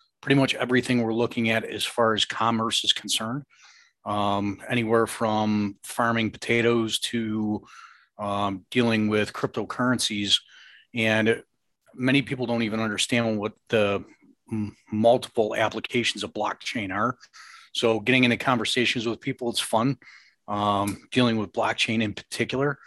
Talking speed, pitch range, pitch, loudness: 130 wpm, 105-125 Hz, 115 Hz, -25 LUFS